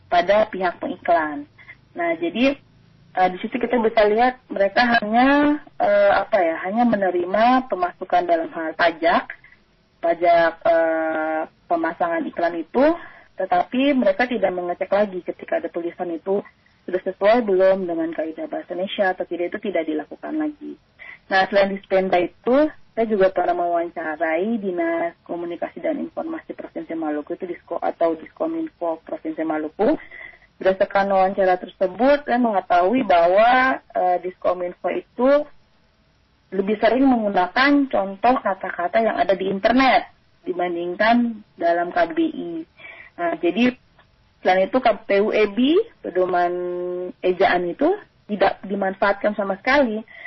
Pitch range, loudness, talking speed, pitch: 180-295 Hz, -21 LUFS, 125 wpm, 215 Hz